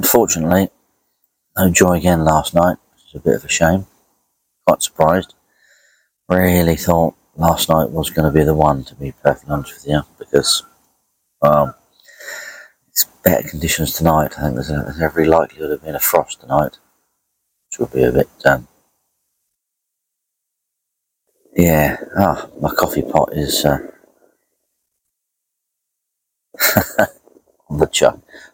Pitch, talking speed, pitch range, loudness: 80 Hz, 140 wpm, 75-85 Hz, -16 LUFS